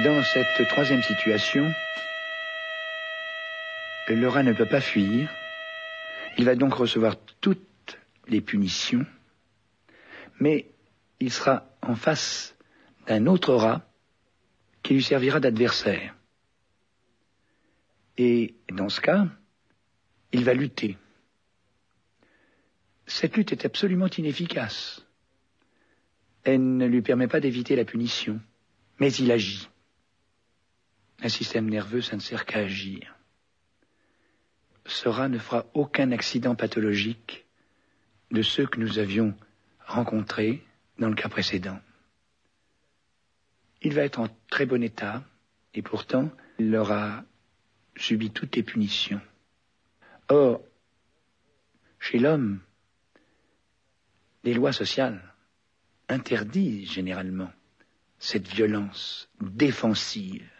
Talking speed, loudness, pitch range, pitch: 100 wpm, -26 LUFS, 105-140 Hz, 115 Hz